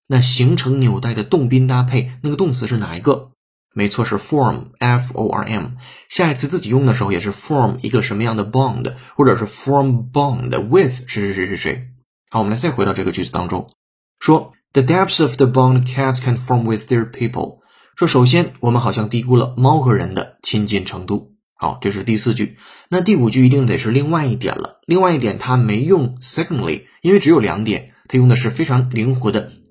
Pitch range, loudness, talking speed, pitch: 110-135 Hz, -17 LUFS, 400 characters per minute, 125 Hz